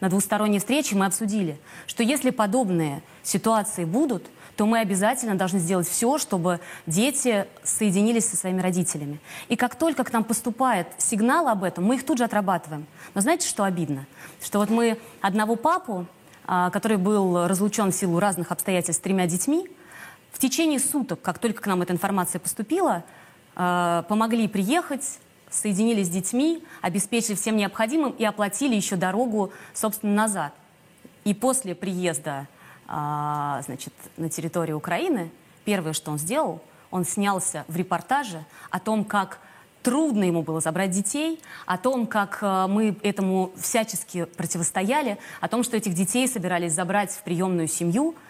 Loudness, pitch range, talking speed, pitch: -24 LUFS, 180-230 Hz, 150 wpm, 200 Hz